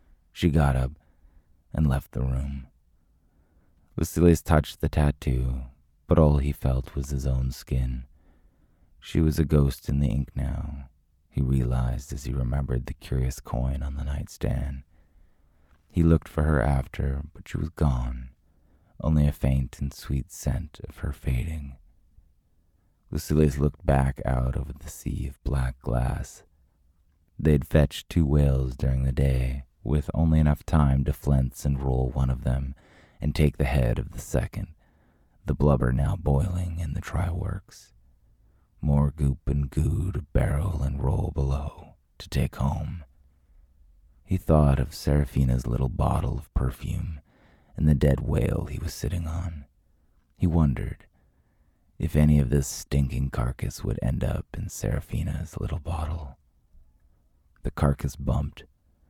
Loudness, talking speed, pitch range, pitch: -27 LUFS, 145 wpm, 65-80 Hz, 70 Hz